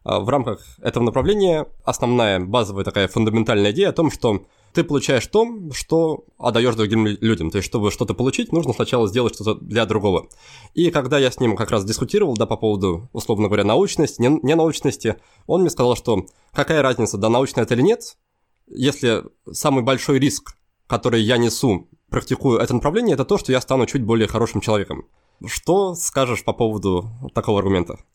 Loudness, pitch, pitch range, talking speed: -20 LUFS, 120 Hz, 110-140 Hz, 175 wpm